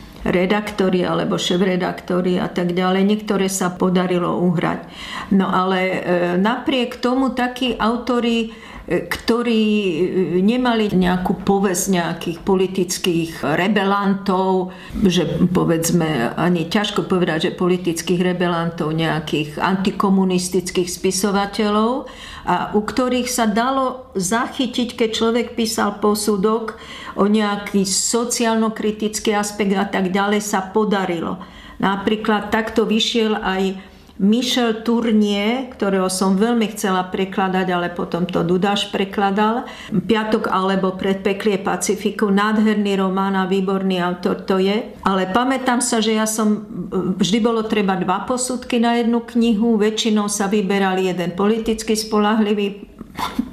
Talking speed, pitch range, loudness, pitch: 115 wpm, 185-225 Hz, -19 LUFS, 205 Hz